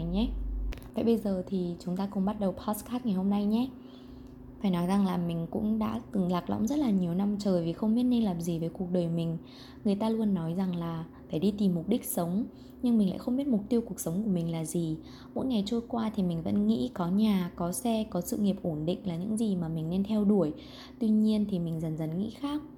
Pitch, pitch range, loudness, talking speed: 195 Hz, 175-220 Hz, -30 LUFS, 260 wpm